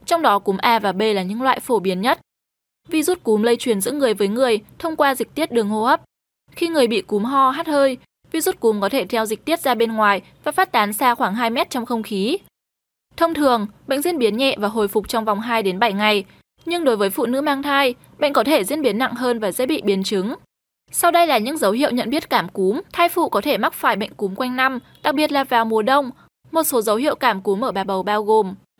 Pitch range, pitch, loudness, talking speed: 215-290 Hz, 245 Hz, -19 LUFS, 260 wpm